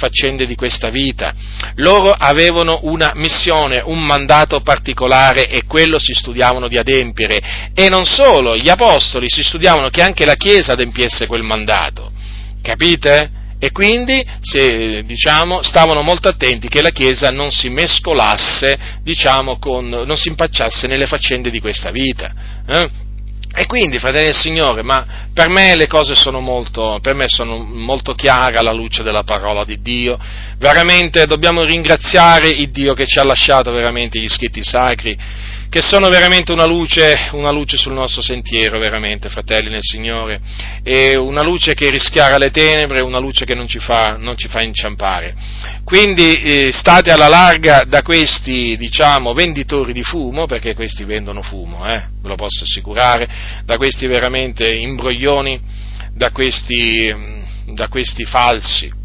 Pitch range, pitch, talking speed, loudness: 110-150 Hz, 125 Hz, 155 wpm, -11 LUFS